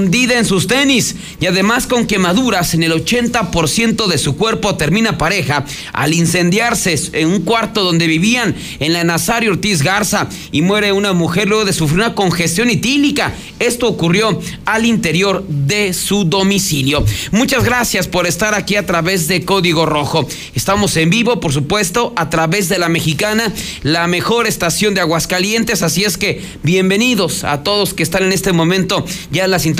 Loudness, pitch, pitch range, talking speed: -13 LUFS, 190 Hz, 165-210 Hz, 165 wpm